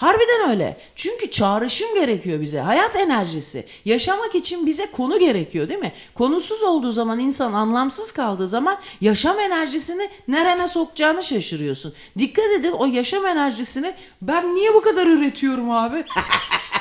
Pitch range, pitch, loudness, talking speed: 230-375 Hz, 310 Hz, -20 LUFS, 135 wpm